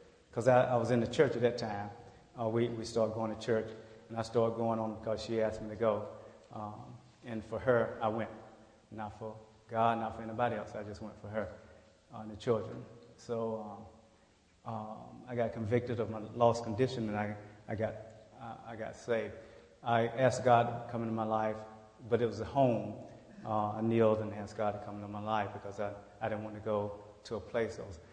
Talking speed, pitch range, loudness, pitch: 220 wpm, 110-115 Hz, -35 LUFS, 110 Hz